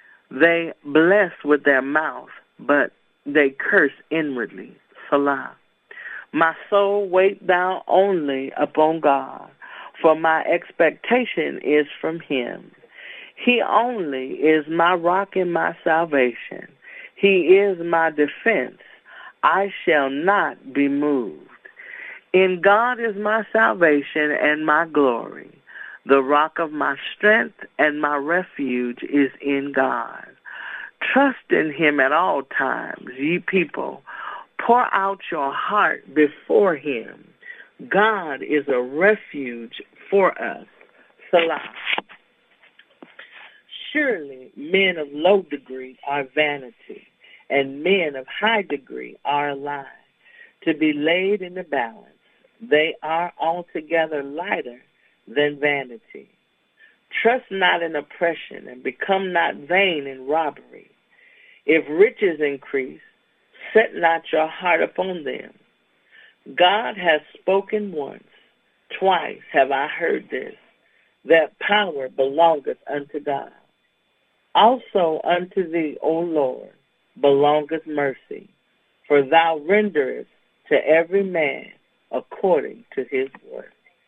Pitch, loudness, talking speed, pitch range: 165 Hz, -20 LUFS, 110 wpm, 145-195 Hz